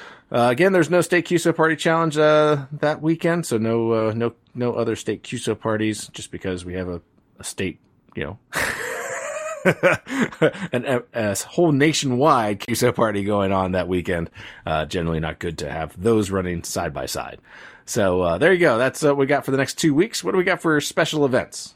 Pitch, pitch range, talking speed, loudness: 125 Hz, 100-160 Hz, 200 wpm, -21 LUFS